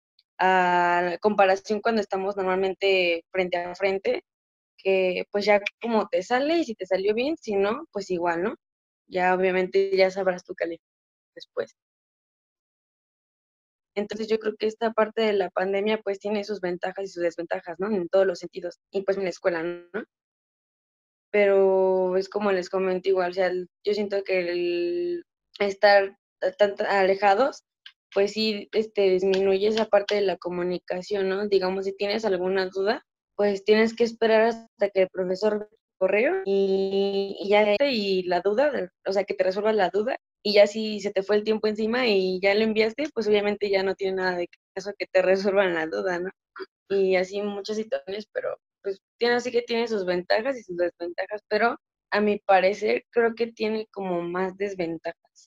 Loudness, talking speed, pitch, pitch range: -25 LUFS, 175 wpm, 200 Hz, 185-215 Hz